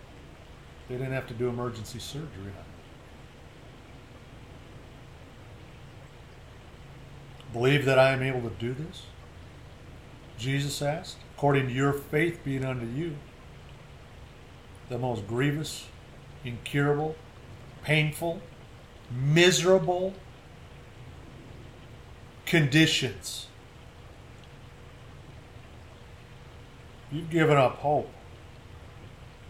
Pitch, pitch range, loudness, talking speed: 130 Hz, 120-150 Hz, -27 LUFS, 75 wpm